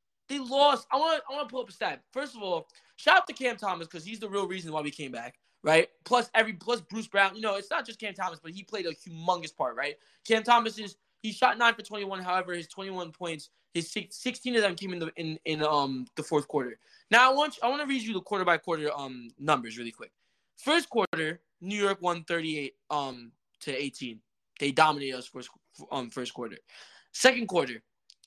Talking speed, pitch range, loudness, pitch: 225 wpm, 155-230 Hz, -29 LUFS, 185 Hz